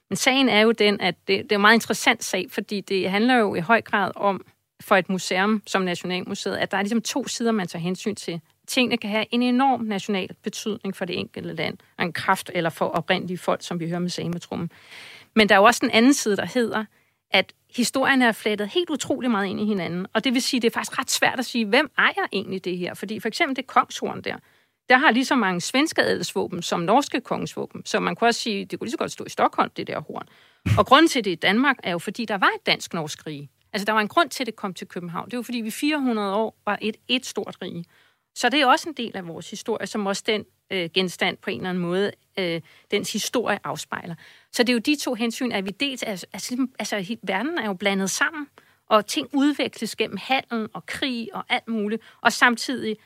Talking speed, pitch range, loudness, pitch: 245 wpm, 190-245 Hz, -23 LUFS, 215 Hz